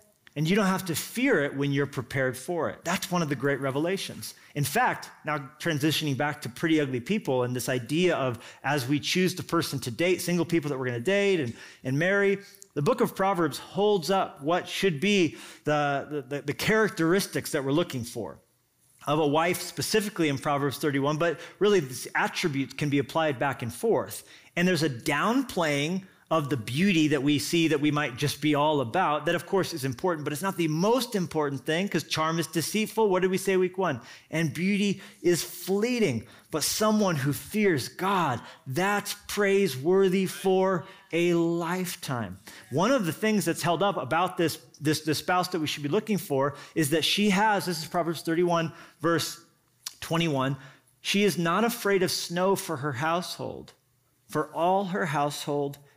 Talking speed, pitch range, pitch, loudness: 190 wpm, 145-190 Hz, 165 Hz, -27 LUFS